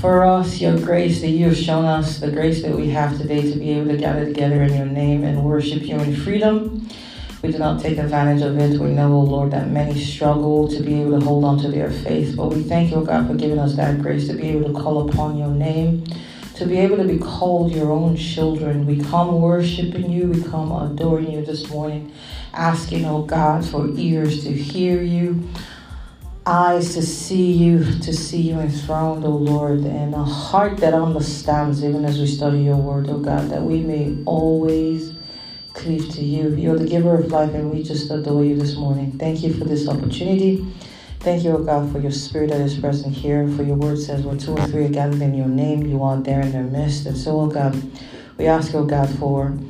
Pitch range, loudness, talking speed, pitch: 145-160 Hz, -19 LUFS, 220 wpm, 150 Hz